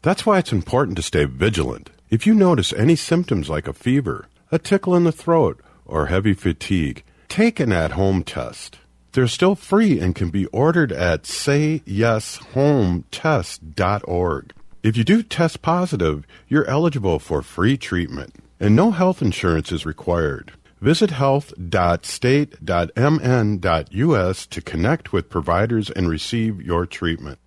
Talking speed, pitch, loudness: 140 wpm, 110 Hz, -20 LUFS